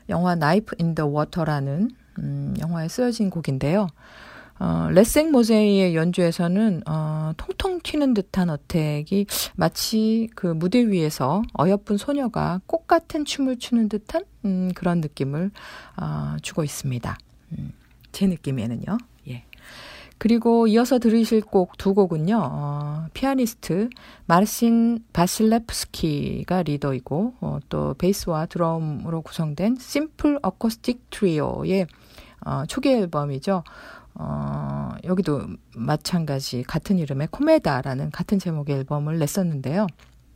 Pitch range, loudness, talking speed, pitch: 150-225 Hz, -23 LUFS, 270 characters per minute, 180 Hz